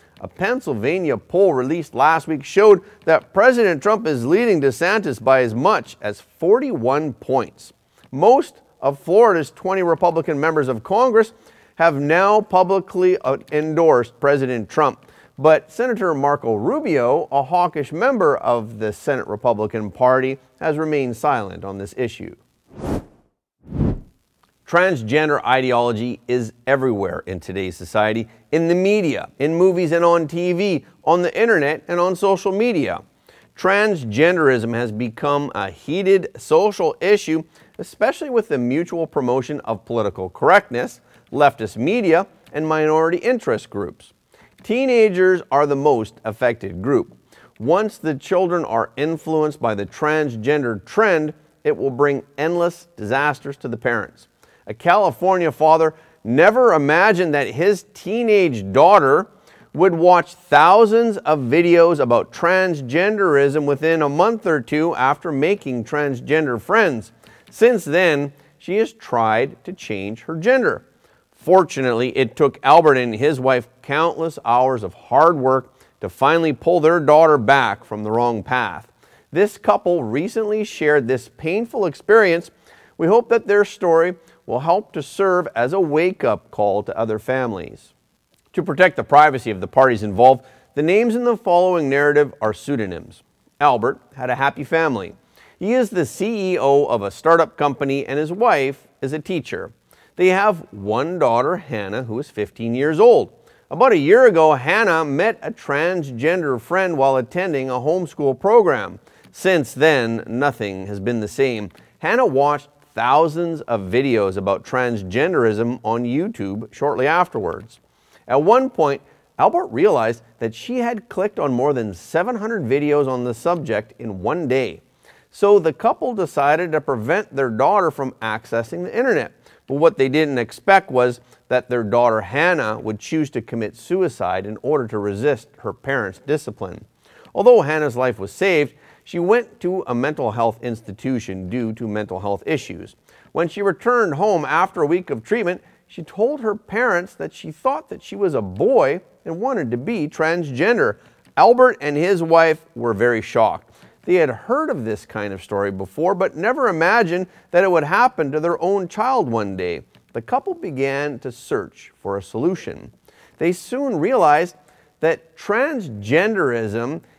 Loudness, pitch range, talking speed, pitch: -18 LUFS, 120-180 Hz, 150 wpm, 150 Hz